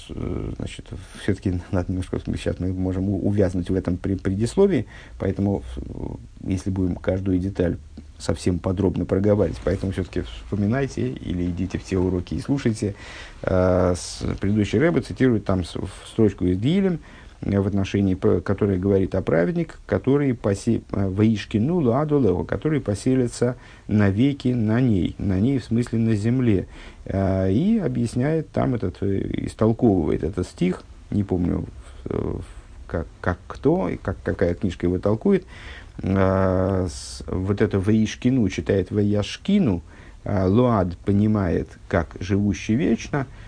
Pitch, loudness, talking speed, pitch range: 100 Hz, -23 LUFS, 120 wpm, 90-115 Hz